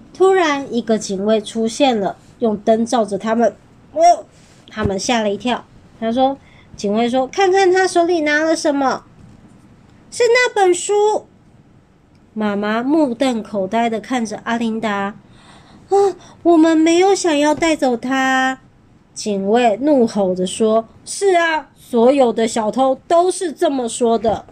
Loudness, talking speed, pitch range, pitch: -16 LUFS, 205 characters per minute, 225-330 Hz, 260 Hz